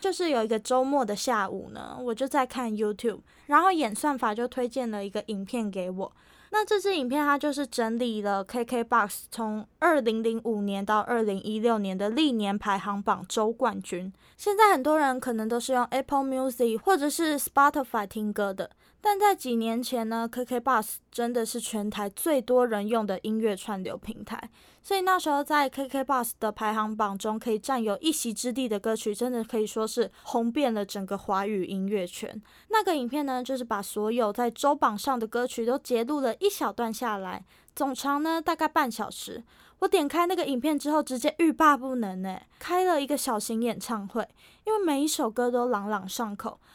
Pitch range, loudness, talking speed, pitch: 215-285 Hz, -27 LUFS, 320 characters per minute, 240 Hz